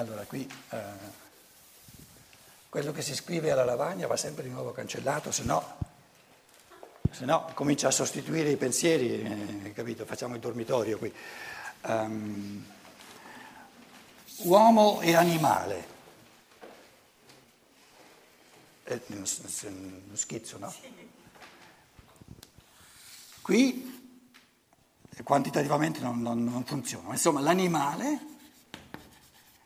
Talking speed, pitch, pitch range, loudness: 95 wpm, 125 Hz, 110-170 Hz, -29 LUFS